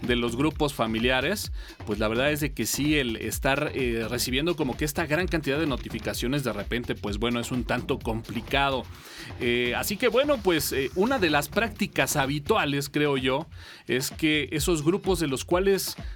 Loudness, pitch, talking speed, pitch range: -26 LUFS, 135 Hz, 185 wpm, 115-155 Hz